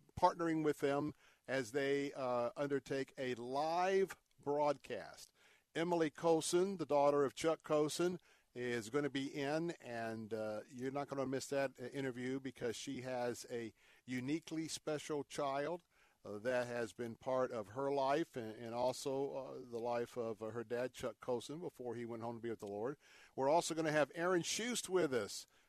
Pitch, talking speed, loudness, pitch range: 135 Hz, 180 wpm, -40 LUFS, 120-150 Hz